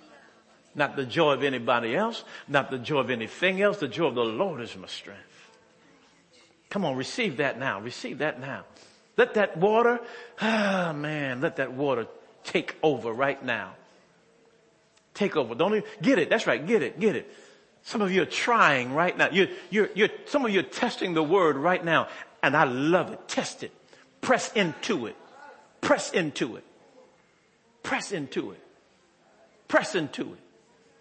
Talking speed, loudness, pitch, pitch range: 180 wpm, -26 LUFS, 165 Hz, 135-210 Hz